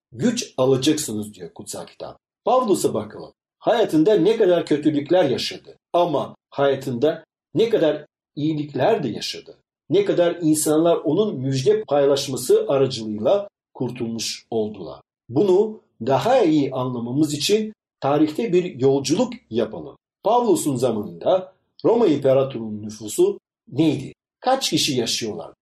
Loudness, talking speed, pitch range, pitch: -21 LUFS, 110 wpm, 130-190 Hz, 150 Hz